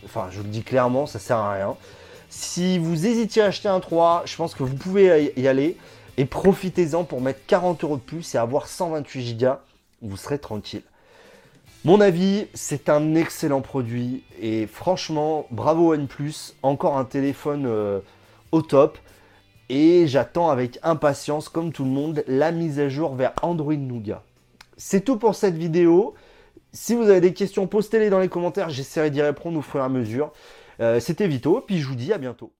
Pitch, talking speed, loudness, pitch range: 150 Hz, 185 wpm, -22 LUFS, 125-175 Hz